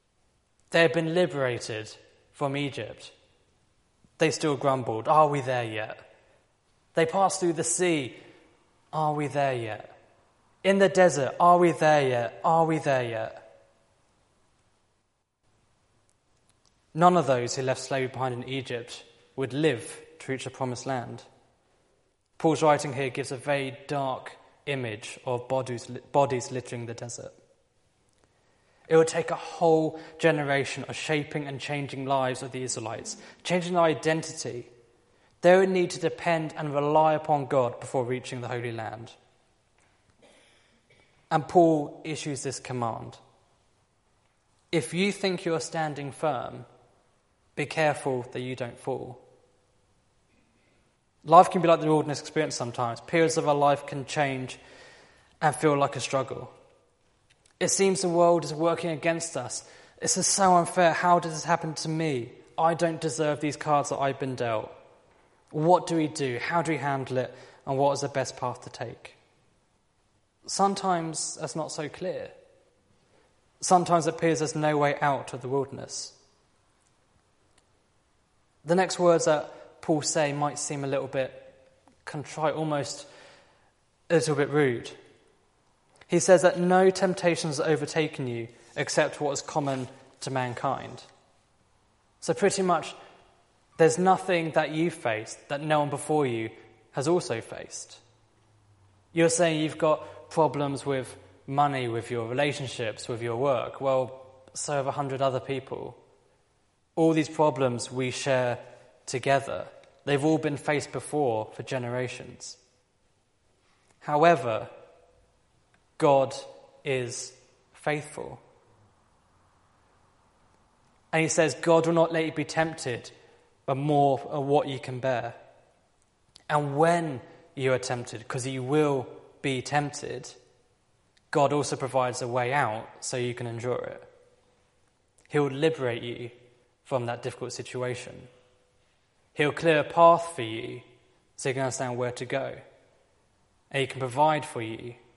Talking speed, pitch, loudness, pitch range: 140 wpm, 135 Hz, -27 LUFS, 120-160 Hz